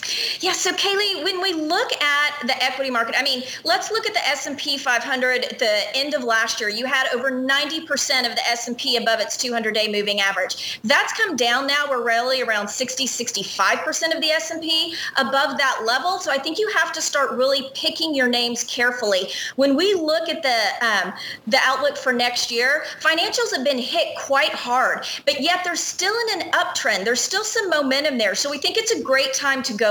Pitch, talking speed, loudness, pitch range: 280 Hz, 205 wpm, -20 LUFS, 245-325 Hz